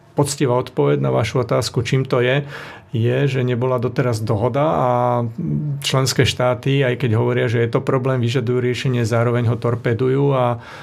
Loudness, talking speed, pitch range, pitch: -19 LUFS, 160 wpm, 120-135 Hz, 125 Hz